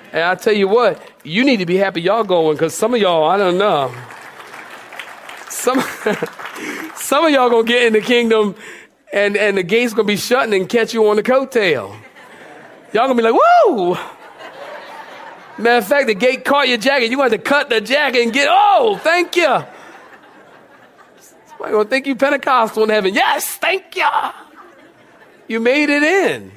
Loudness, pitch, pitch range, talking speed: -15 LUFS, 240 Hz, 215-285 Hz, 185 wpm